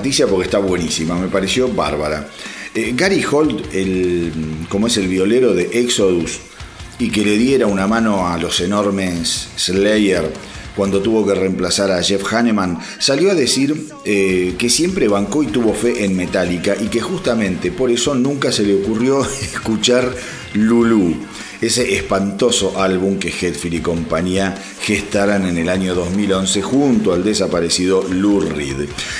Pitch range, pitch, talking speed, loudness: 90-115 Hz, 100 Hz, 150 wpm, -16 LUFS